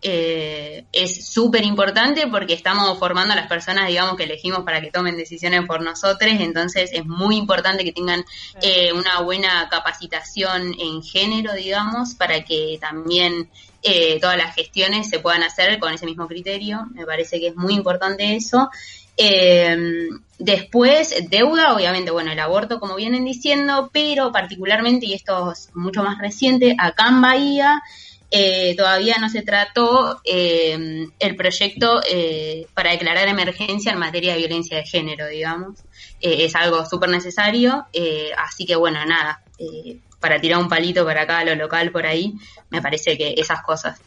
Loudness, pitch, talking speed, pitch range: -18 LUFS, 180 Hz, 160 wpm, 165-205 Hz